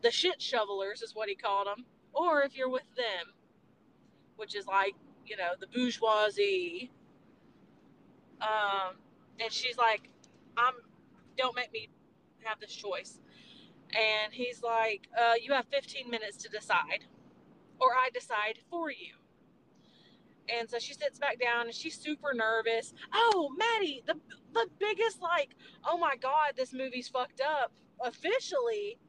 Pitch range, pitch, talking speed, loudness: 220-320 Hz, 250 Hz, 145 wpm, -32 LUFS